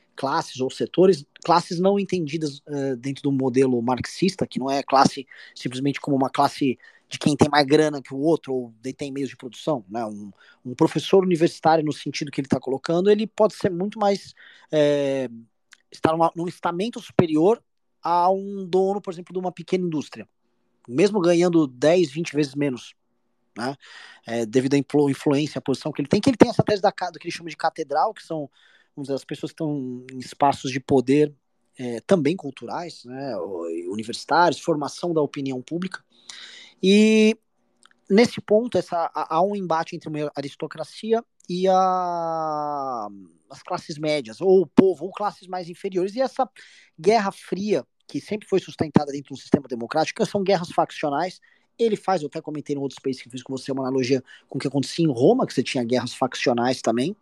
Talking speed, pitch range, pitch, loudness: 180 wpm, 135-185 Hz, 155 Hz, -23 LUFS